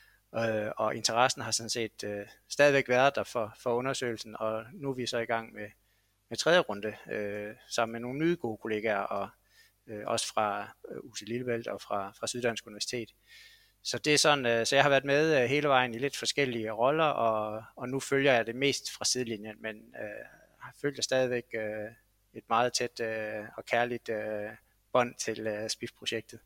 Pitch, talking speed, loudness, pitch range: 115 Hz, 190 wpm, -30 LUFS, 110-125 Hz